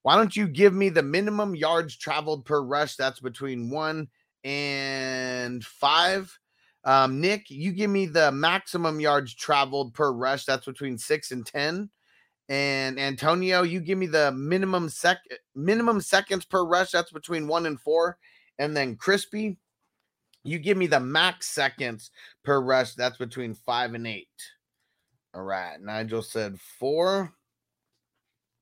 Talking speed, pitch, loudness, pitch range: 145 wpm, 150 Hz, -25 LUFS, 130-180 Hz